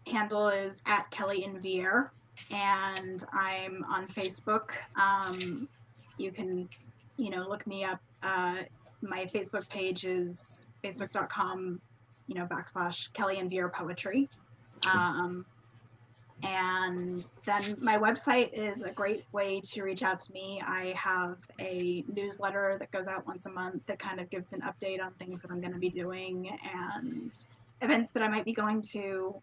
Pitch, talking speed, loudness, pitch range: 190 Hz, 155 wpm, -33 LUFS, 180-200 Hz